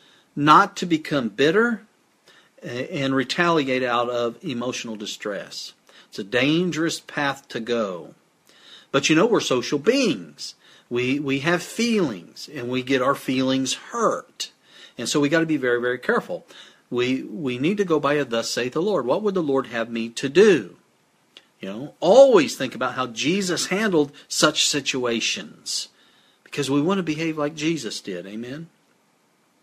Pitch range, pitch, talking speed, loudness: 125-165 Hz, 140 Hz, 160 wpm, -22 LUFS